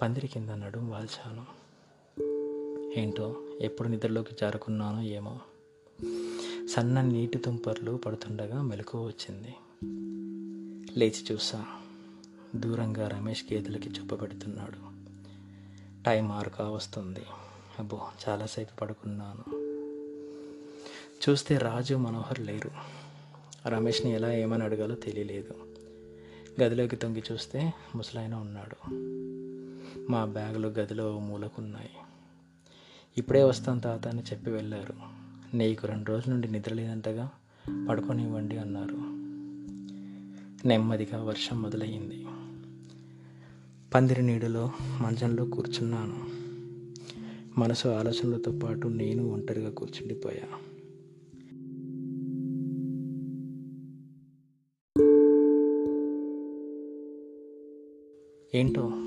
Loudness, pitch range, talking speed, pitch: -32 LUFS, 105-130 Hz, 75 wpm, 115 Hz